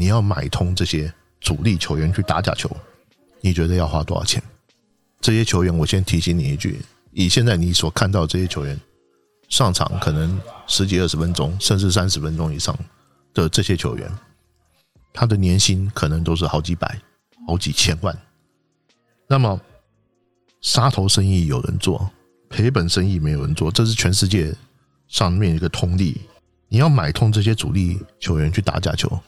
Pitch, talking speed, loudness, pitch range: 90 Hz, 255 characters per minute, -19 LUFS, 80-105 Hz